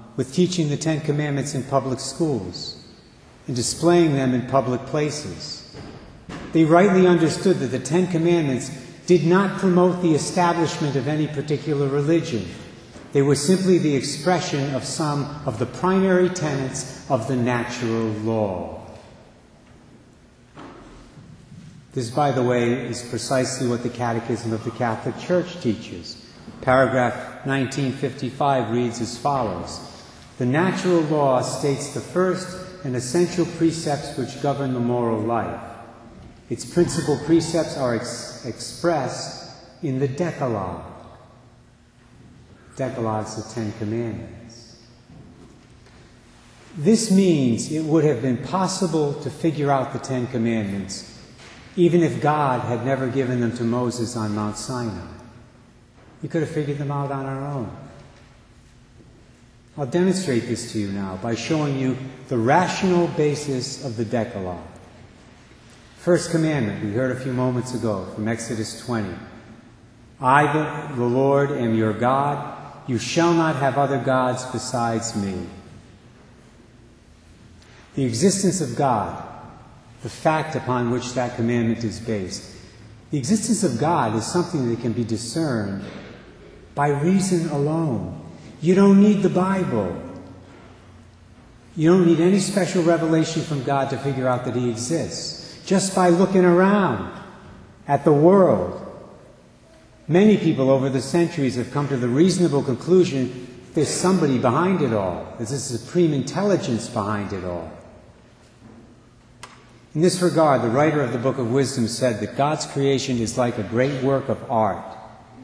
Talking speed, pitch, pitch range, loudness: 135 wpm, 130 Hz, 115-155 Hz, -22 LUFS